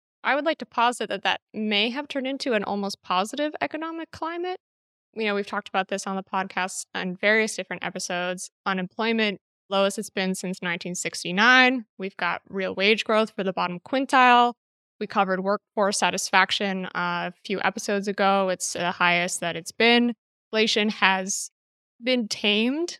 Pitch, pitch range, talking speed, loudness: 200 Hz, 185-230 Hz, 165 wpm, -24 LUFS